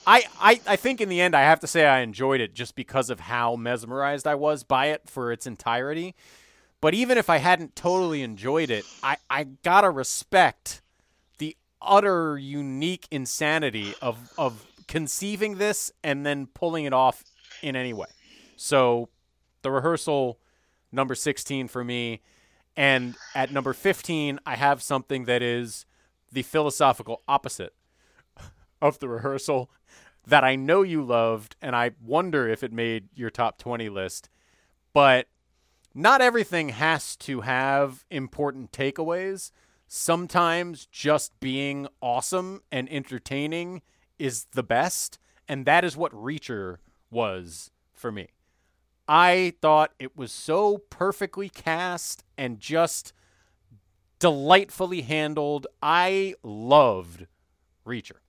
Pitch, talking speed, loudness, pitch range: 135 Hz, 135 wpm, -24 LUFS, 120-160 Hz